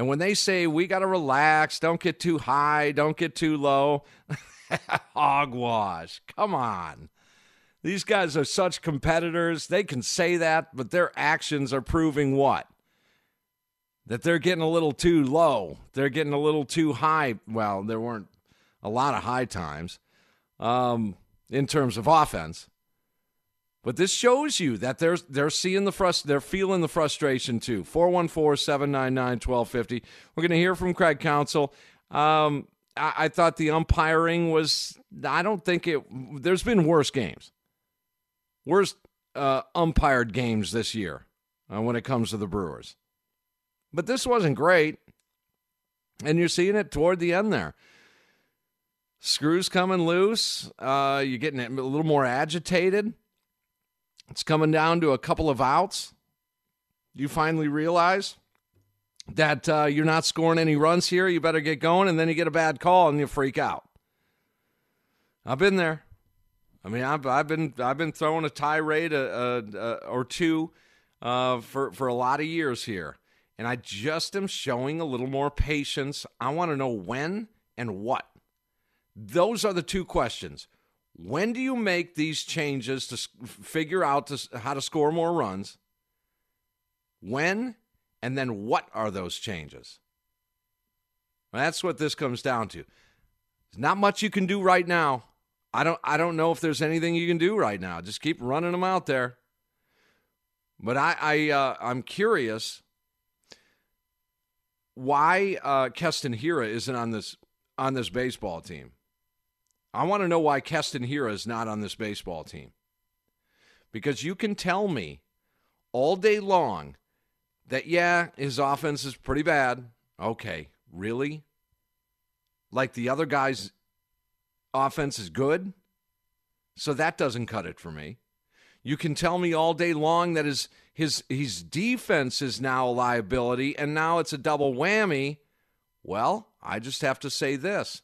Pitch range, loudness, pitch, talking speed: 125-170 Hz, -26 LUFS, 145 Hz, 155 wpm